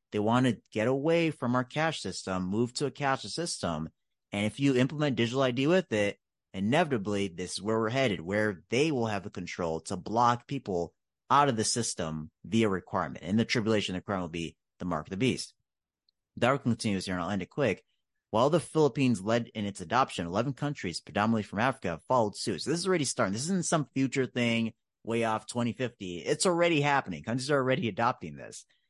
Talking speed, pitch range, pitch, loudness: 205 wpm, 100-135 Hz, 115 Hz, -30 LUFS